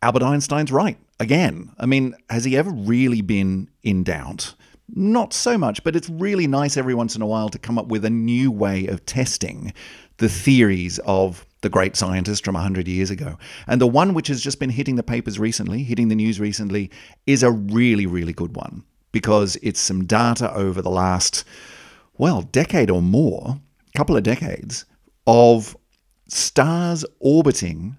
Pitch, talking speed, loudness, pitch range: 115 Hz, 175 wpm, -20 LUFS, 95-135 Hz